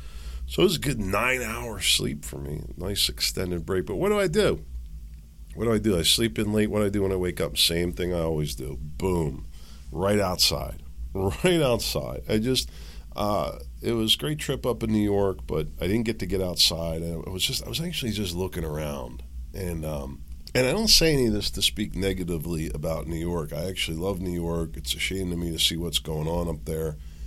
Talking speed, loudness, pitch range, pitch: 225 wpm, -26 LUFS, 75-105 Hz, 85 Hz